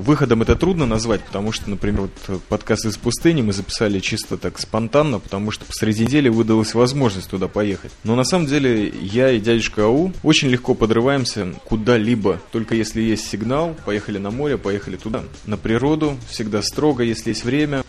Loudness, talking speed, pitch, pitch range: -19 LUFS, 175 wpm, 115 Hz, 105-125 Hz